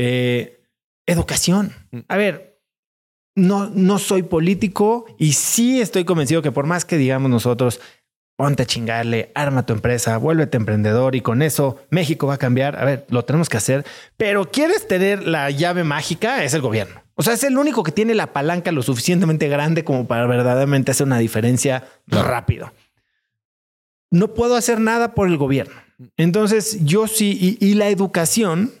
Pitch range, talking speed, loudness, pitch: 125-195 Hz, 170 wpm, -18 LUFS, 155 Hz